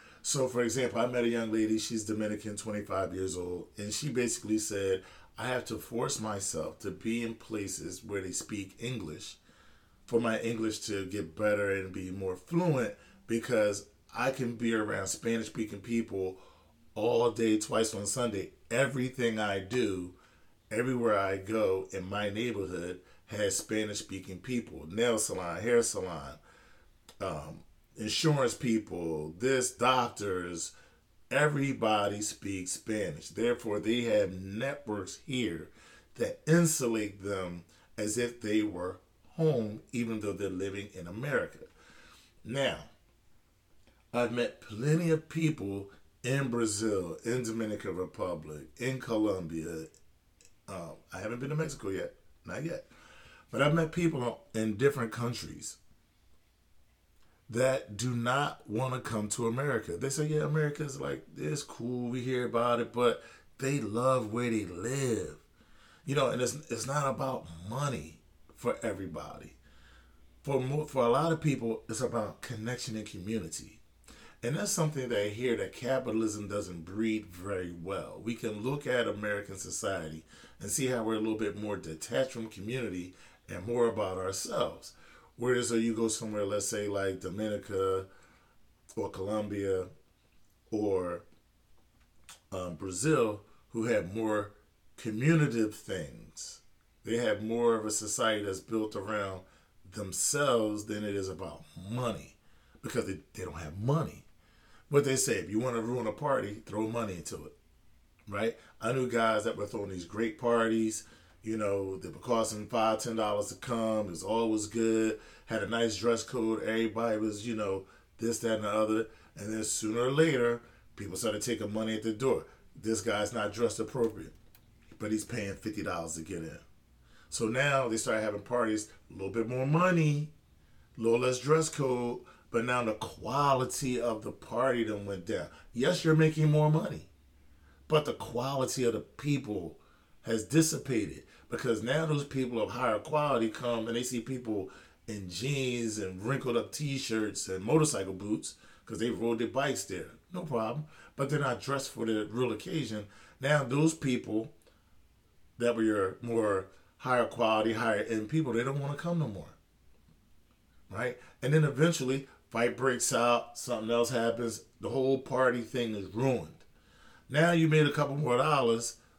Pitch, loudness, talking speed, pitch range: 110 Hz, -32 LUFS, 155 wpm, 100-125 Hz